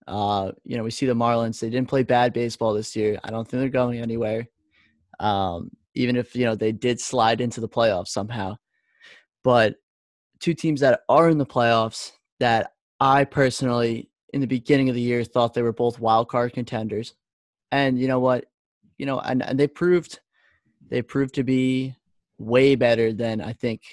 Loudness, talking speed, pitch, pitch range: -23 LUFS, 190 wpm, 120 Hz, 110-130 Hz